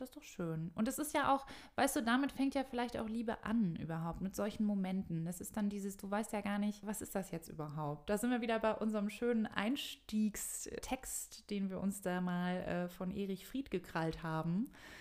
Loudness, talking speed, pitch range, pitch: -39 LUFS, 220 wpm, 185-240 Hz, 210 Hz